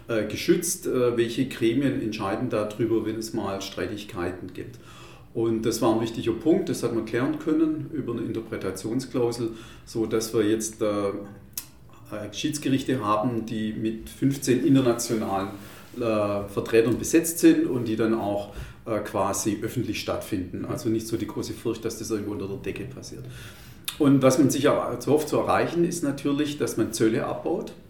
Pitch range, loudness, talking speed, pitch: 110-125 Hz, -26 LUFS, 155 wpm, 115 Hz